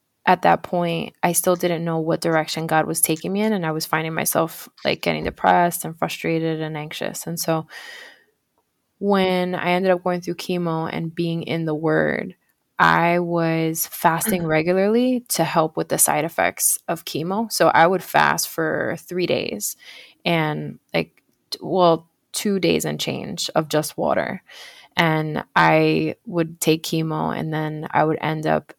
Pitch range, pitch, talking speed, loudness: 155-180 Hz, 165 Hz, 165 wpm, -21 LUFS